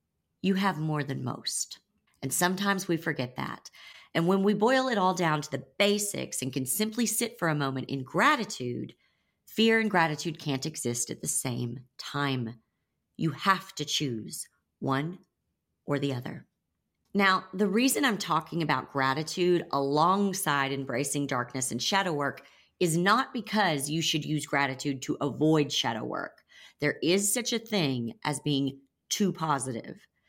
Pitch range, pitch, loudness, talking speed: 135-195 Hz, 155 Hz, -28 LUFS, 155 wpm